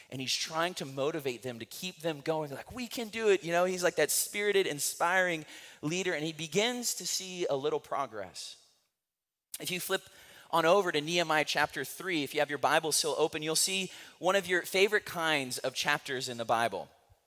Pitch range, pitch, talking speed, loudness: 150-185 Hz, 165 Hz, 210 wpm, -31 LUFS